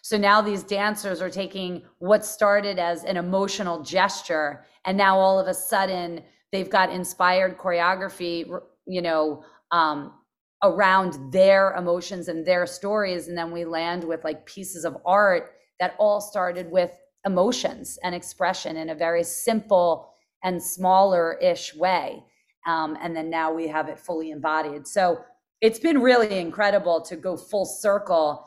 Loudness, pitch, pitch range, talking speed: -23 LUFS, 185 Hz, 170-200 Hz, 155 wpm